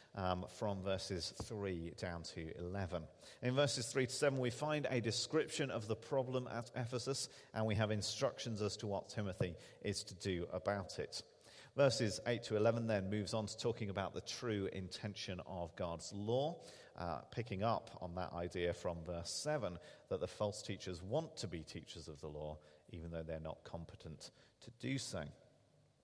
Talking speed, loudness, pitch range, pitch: 180 wpm, -42 LUFS, 90-120 Hz, 105 Hz